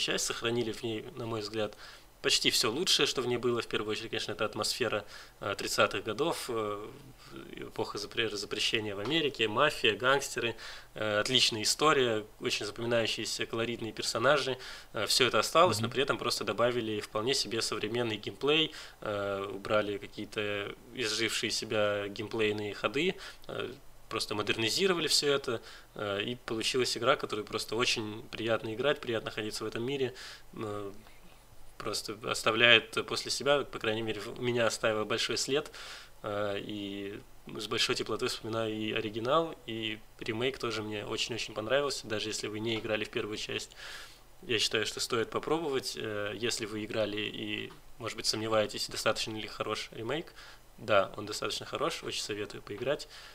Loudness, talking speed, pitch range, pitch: -31 LUFS, 145 wpm, 105-115 Hz, 110 Hz